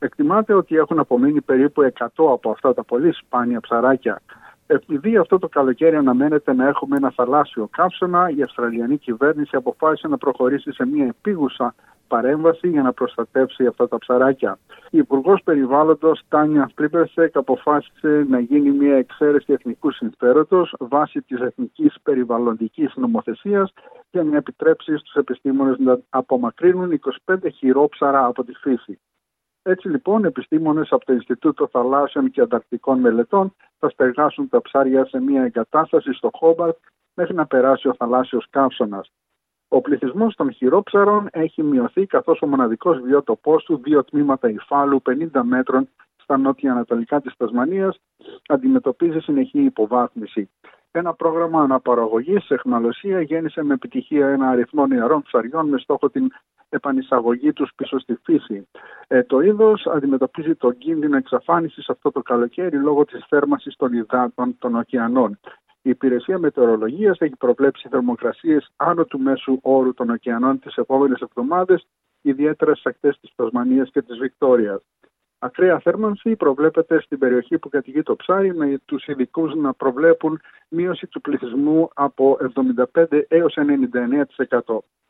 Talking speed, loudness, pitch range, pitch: 140 wpm, -19 LUFS, 130-165 Hz, 145 Hz